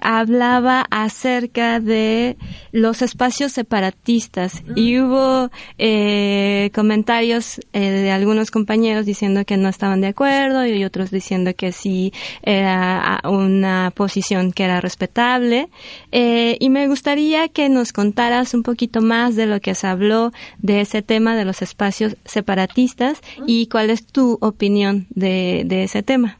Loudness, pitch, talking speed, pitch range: -17 LUFS, 220 Hz, 140 wpm, 195-245 Hz